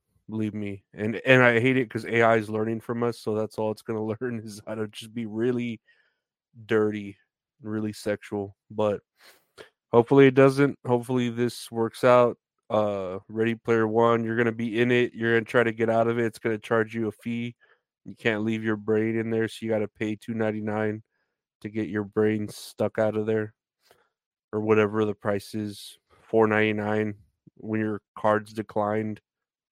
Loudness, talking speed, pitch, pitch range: -25 LUFS, 190 wpm, 110 Hz, 105-115 Hz